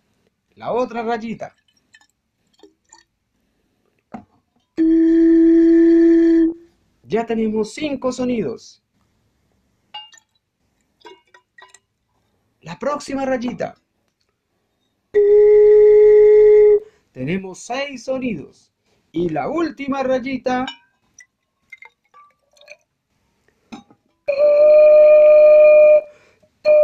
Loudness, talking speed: -14 LUFS, 40 wpm